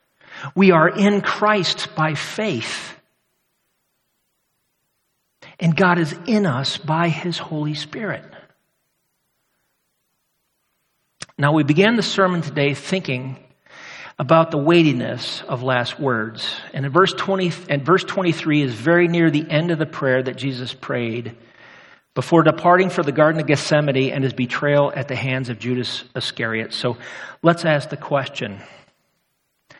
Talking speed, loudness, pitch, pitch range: 135 wpm, -19 LUFS, 150 Hz, 130-170 Hz